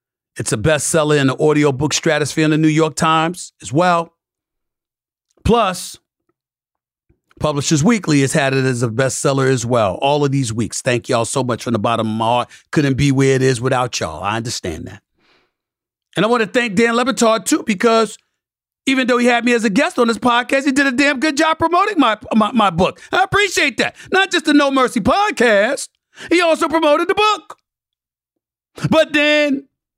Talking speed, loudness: 195 wpm, -16 LUFS